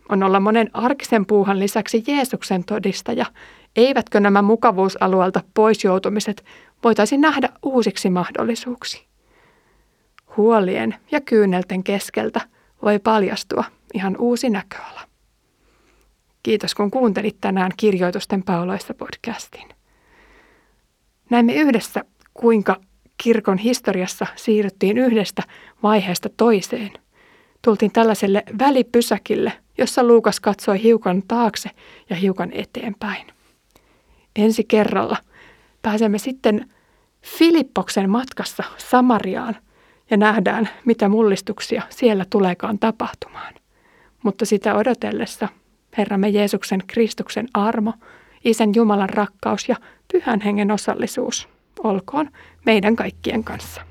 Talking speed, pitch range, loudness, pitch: 95 wpm, 205-235 Hz, -19 LUFS, 220 Hz